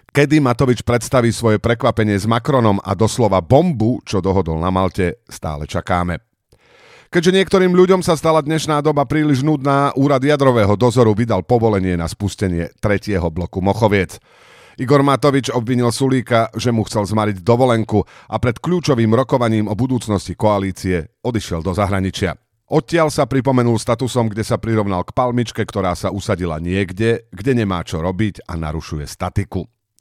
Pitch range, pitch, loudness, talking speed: 95-130 Hz, 115 Hz, -17 LUFS, 150 wpm